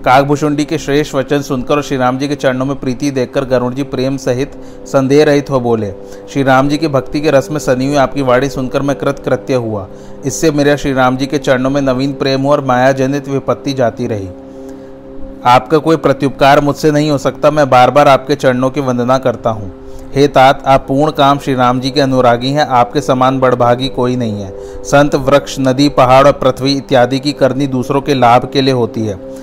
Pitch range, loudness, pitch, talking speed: 125-140 Hz, -12 LUFS, 135 Hz, 210 wpm